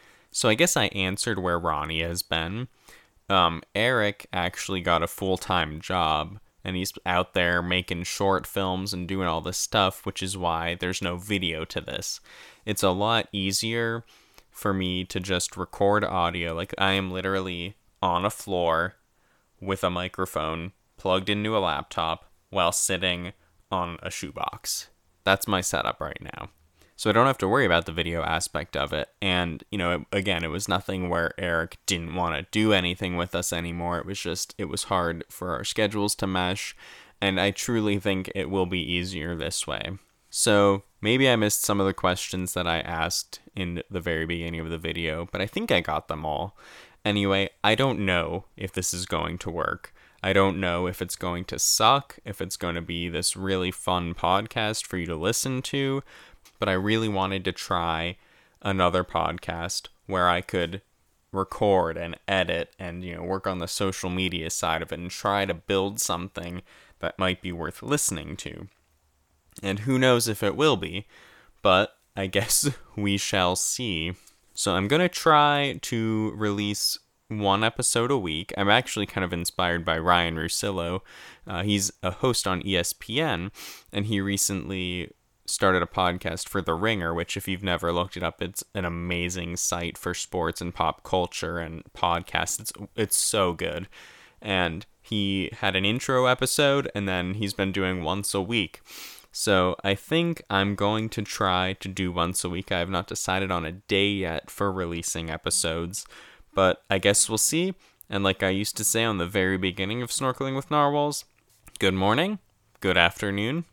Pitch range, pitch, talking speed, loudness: 85-100 Hz, 95 Hz, 180 wpm, -26 LUFS